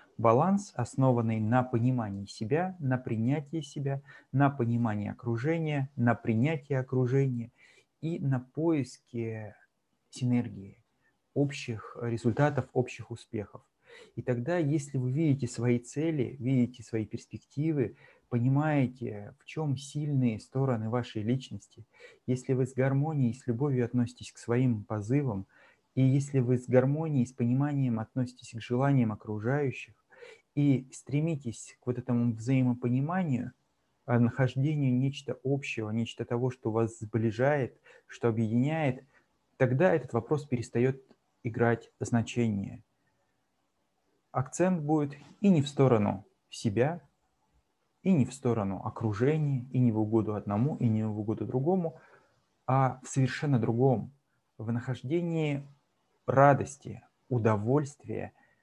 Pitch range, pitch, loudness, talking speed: 115-140 Hz, 125 Hz, -30 LUFS, 115 wpm